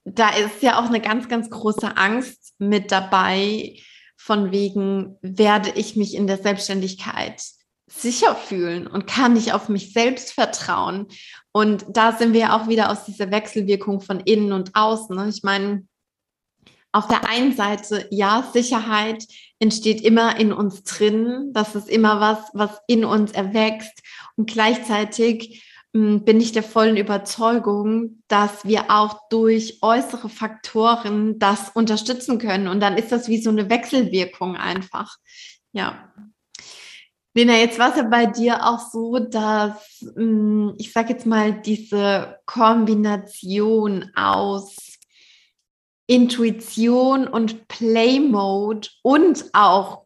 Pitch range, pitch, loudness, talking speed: 205-230 Hz, 215 Hz, -19 LUFS, 130 wpm